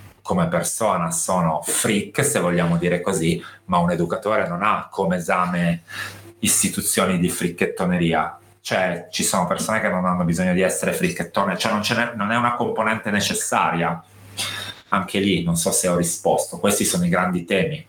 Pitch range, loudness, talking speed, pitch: 85-105 Hz, -21 LUFS, 165 wpm, 90 Hz